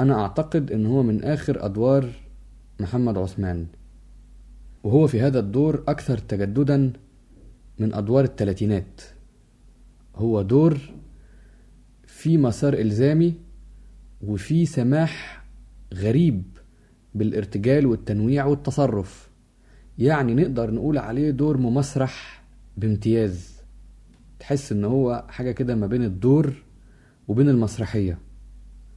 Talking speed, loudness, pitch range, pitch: 95 wpm, -22 LUFS, 105-140 Hz, 120 Hz